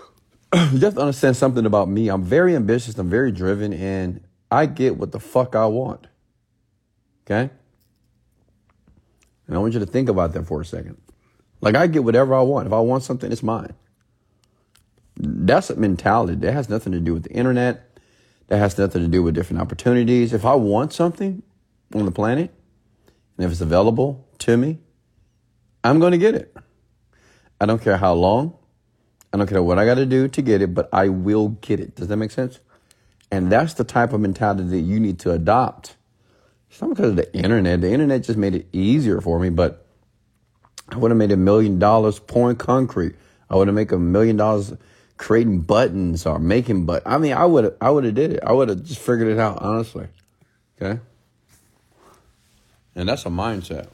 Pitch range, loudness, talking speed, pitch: 95-120 Hz, -19 LUFS, 195 wpm, 110 Hz